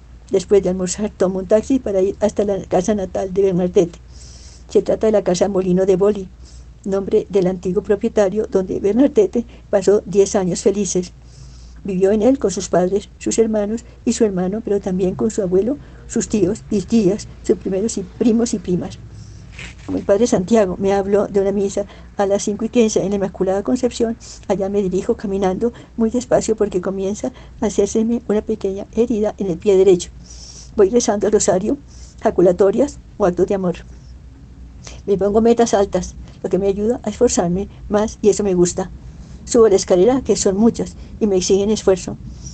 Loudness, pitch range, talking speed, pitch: -18 LUFS, 185-220 Hz, 180 wpm, 200 Hz